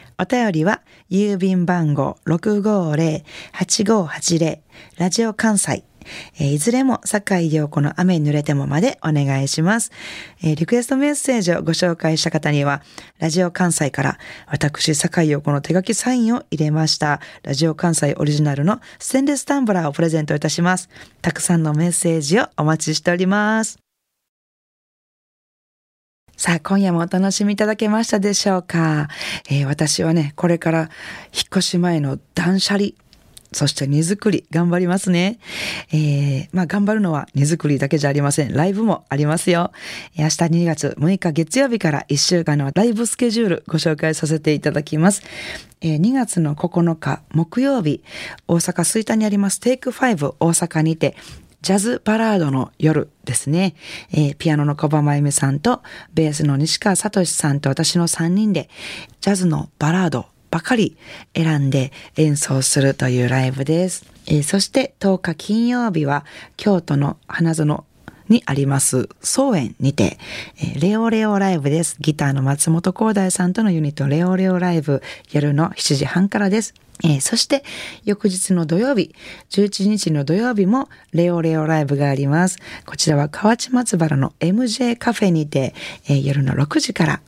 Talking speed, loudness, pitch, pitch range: 270 characters per minute, -18 LUFS, 165 Hz, 150-200 Hz